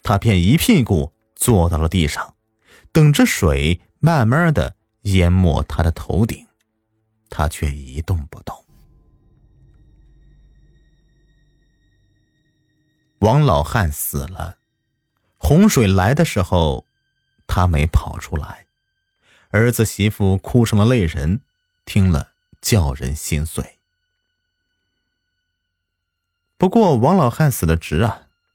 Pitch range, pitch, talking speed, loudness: 85-125 Hz, 105 Hz, 145 characters per minute, -17 LUFS